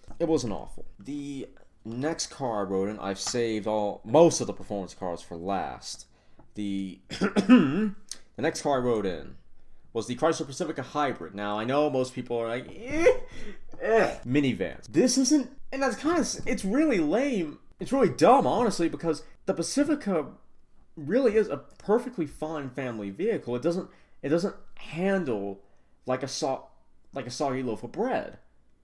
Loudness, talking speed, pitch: -27 LUFS, 160 wpm, 145 Hz